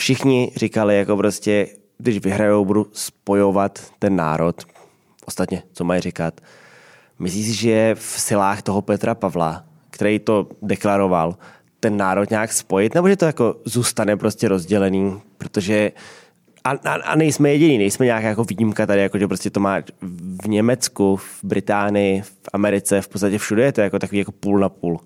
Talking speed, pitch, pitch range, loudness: 165 wpm, 100 Hz, 95-110 Hz, -19 LUFS